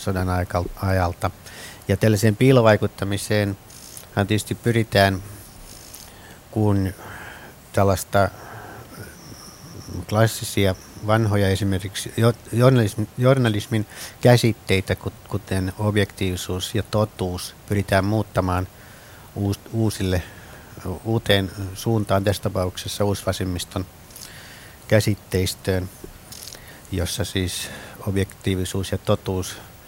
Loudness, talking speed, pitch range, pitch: -22 LUFS, 65 wpm, 95-110 Hz, 100 Hz